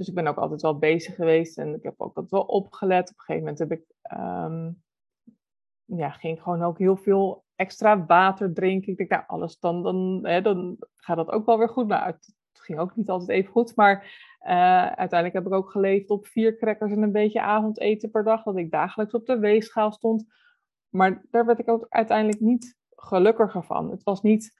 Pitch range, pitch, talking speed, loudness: 180-225 Hz, 200 Hz, 215 wpm, -24 LUFS